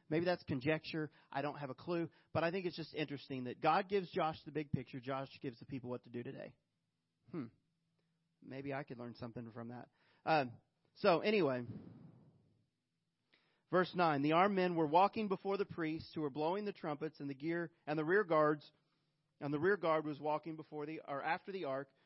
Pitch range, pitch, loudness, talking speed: 140-165 Hz, 155 Hz, -38 LUFS, 200 wpm